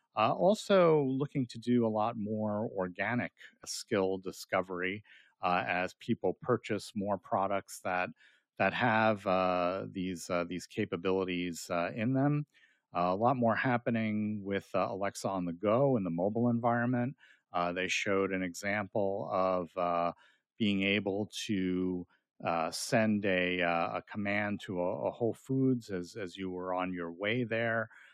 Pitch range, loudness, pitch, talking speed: 90-115 Hz, -33 LUFS, 100 Hz, 155 wpm